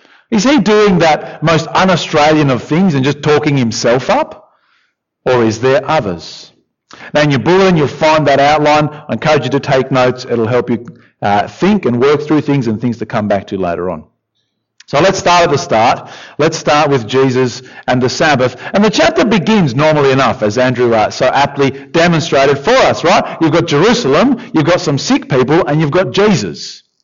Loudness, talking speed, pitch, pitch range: -11 LUFS, 195 wpm, 150 Hz, 125-170 Hz